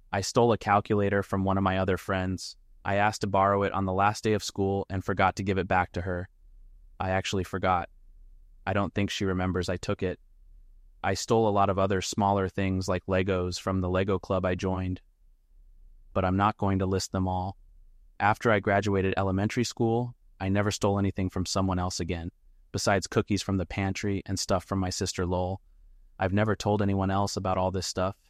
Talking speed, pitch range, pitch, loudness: 205 wpm, 90-100 Hz, 95 Hz, -28 LUFS